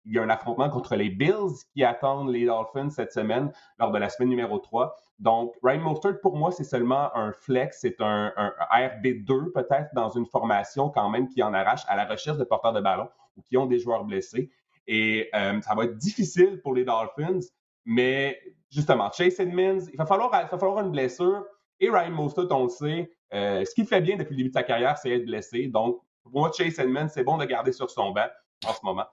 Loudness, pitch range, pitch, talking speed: -26 LUFS, 120-180 Hz, 135 Hz, 230 wpm